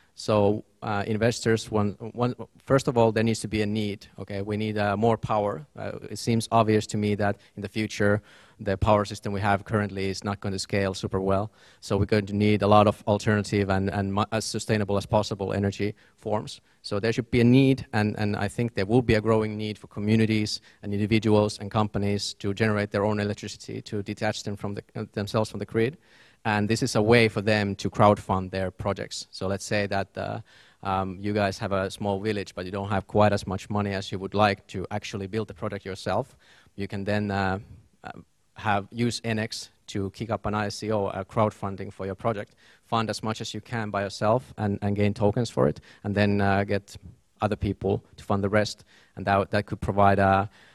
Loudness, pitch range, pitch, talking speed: -26 LUFS, 100-110 Hz, 105 Hz, 220 wpm